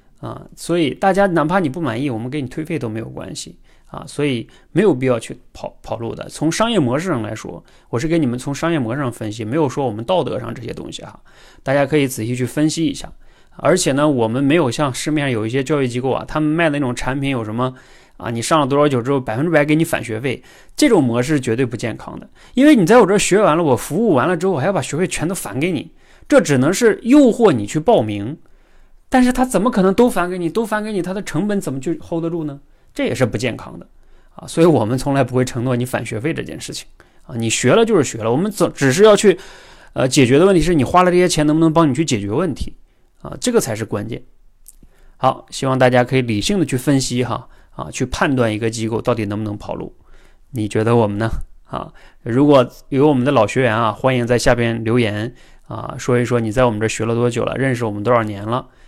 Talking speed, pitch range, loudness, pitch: 360 characters per minute, 120-165 Hz, -17 LUFS, 135 Hz